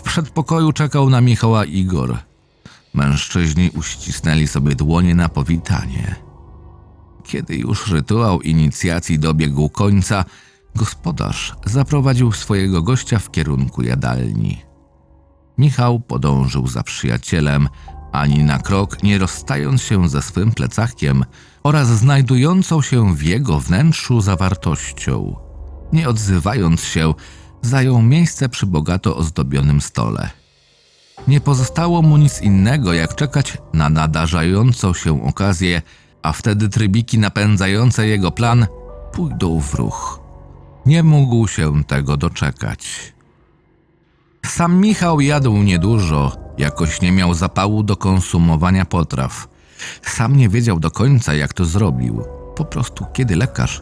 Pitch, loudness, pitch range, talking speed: 90 Hz, -16 LUFS, 75-115 Hz, 115 wpm